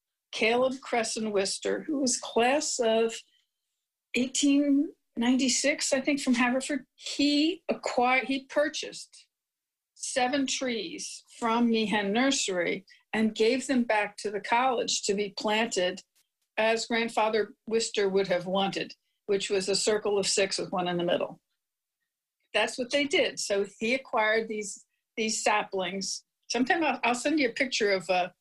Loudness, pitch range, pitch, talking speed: -28 LUFS, 205-265 Hz, 230 Hz, 140 wpm